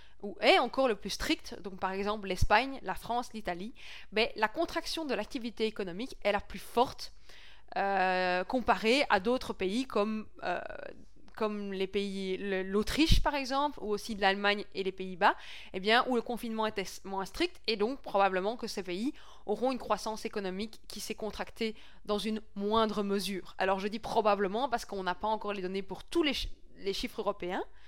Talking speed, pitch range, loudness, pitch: 185 wpm, 195-235 Hz, -32 LUFS, 210 Hz